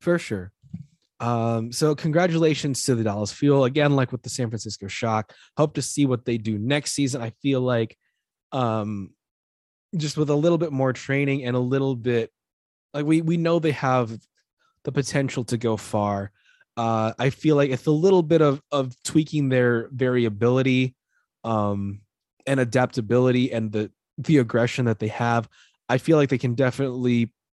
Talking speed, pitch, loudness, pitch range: 170 wpm, 130 Hz, -23 LUFS, 115-145 Hz